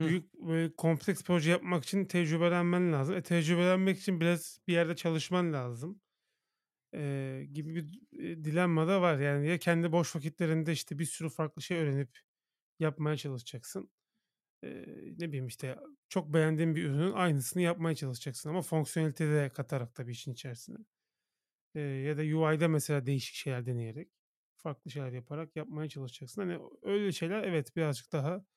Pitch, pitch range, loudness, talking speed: 160 Hz, 145-175 Hz, -33 LUFS, 155 wpm